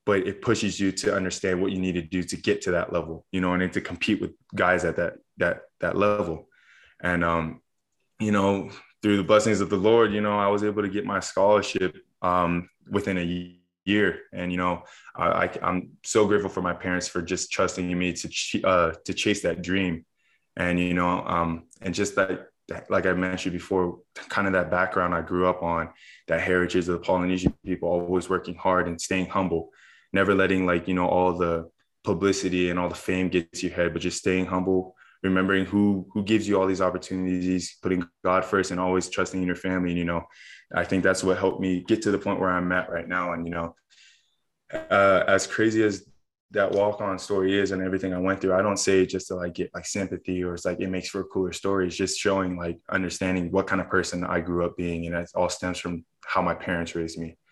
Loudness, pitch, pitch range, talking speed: -25 LUFS, 90 Hz, 90-95 Hz, 225 wpm